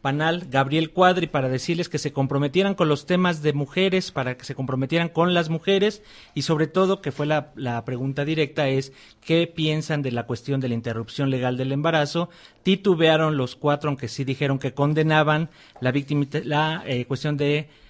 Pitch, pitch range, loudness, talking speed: 150 Hz, 135-165 Hz, -23 LUFS, 180 wpm